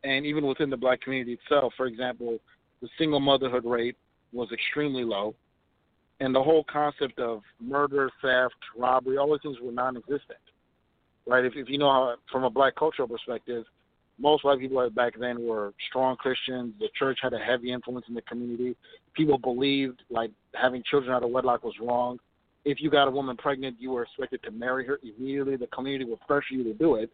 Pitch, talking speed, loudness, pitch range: 130 Hz, 190 wpm, -28 LUFS, 120-140 Hz